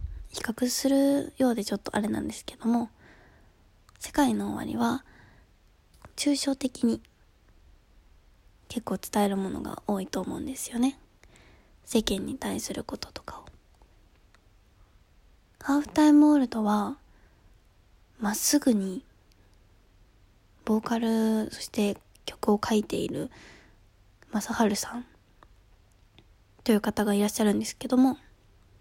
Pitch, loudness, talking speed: 205 Hz, -27 LUFS, 235 characters per minute